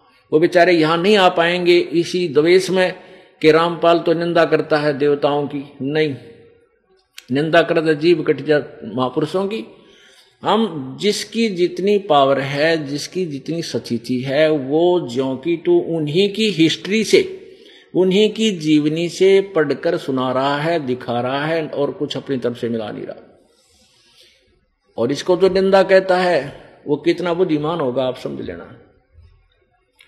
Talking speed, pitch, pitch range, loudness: 145 wpm, 165 Hz, 145-185 Hz, -17 LUFS